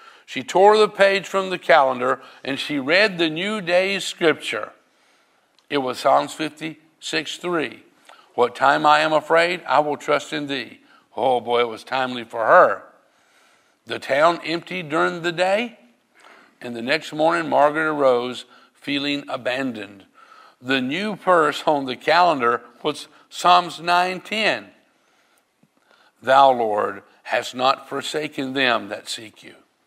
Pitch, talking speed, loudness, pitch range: 155 Hz, 140 wpm, -20 LUFS, 140-180 Hz